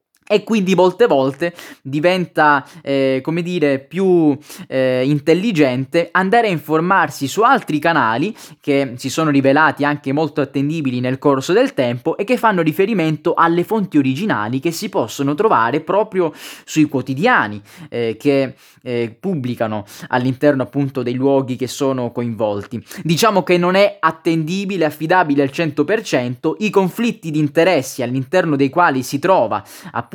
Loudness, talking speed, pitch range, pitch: -17 LUFS, 140 wpm, 135-180 Hz, 150 Hz